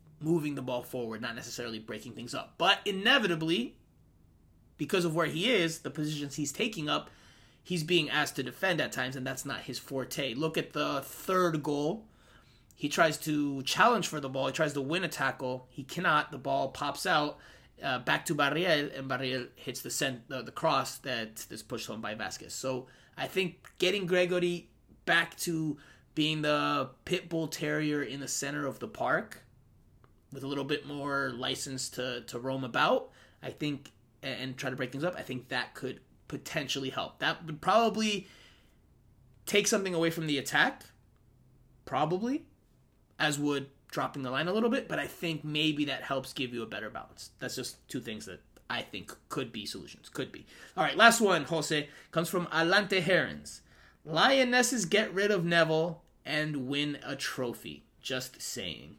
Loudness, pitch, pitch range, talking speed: -31 LUFS, 150 Hz, 130-170 Hz, 180 wpm